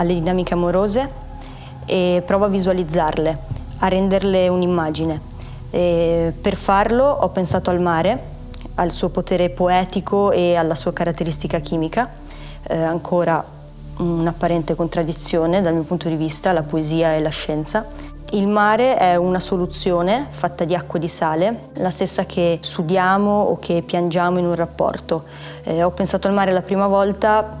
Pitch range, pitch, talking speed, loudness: 165-190 Hz, 175 Hz, 150 wpm, -19 LUFS